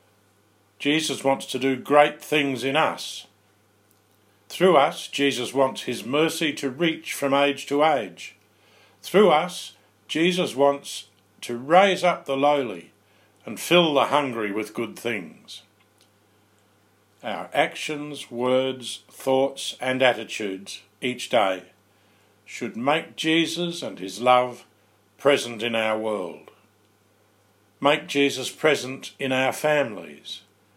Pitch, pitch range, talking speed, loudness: 125 Hz, 105-140 Hz, 115 wpm, -23 LUFS